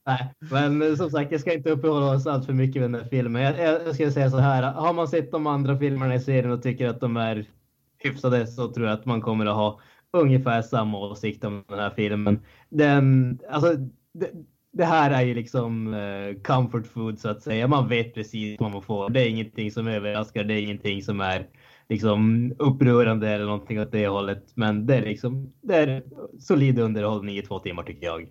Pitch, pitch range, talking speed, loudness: 120 Hz, 105-135 Hz, 210 wpm, -24 LUFS